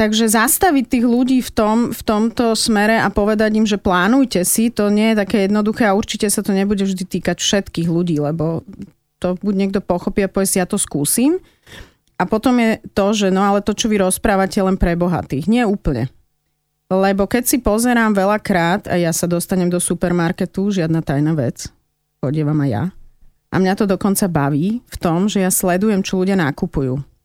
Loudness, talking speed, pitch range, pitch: -17 LUFS, 190 wpm, 175-215 Hz, 195 Hz